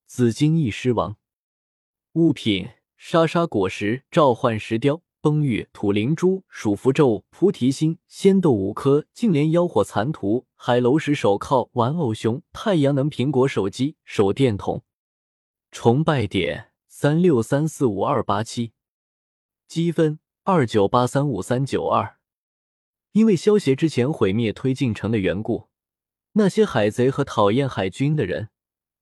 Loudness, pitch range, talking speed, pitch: -21 LUFS, 110-155 Hz, 205 characters per minute, 130 Hz